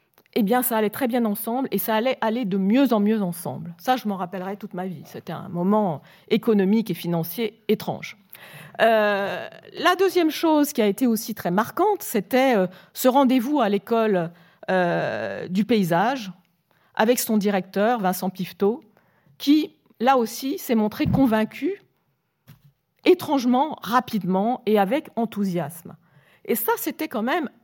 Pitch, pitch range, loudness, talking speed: 215 Hz, 185-255 Hz, -23 LUFS, 150 wpm